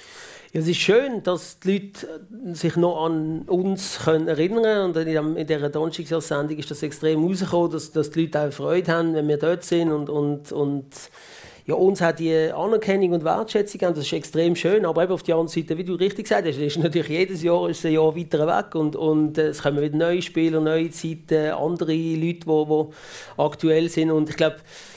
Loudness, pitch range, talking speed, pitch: -22 LUFS, 155-175 Hz, 195 wpm, 165 Hz